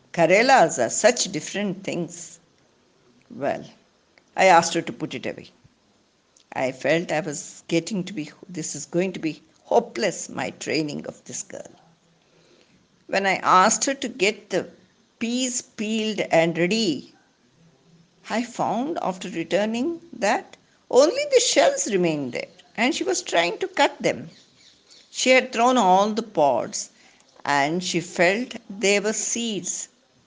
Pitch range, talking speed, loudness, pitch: 170-235 Hz, 140 wpm, -22 LUFS, 190 Hz